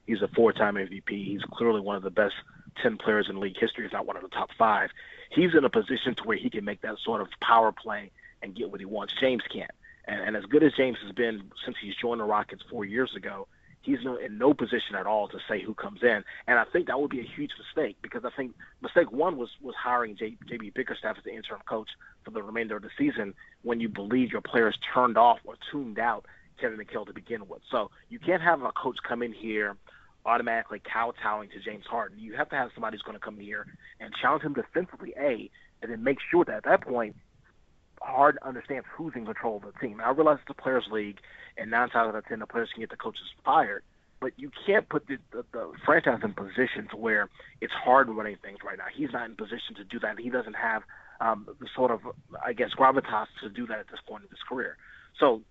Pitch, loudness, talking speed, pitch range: 115 Hz, -29 LUFS, 245 wpm, 105-125 Hz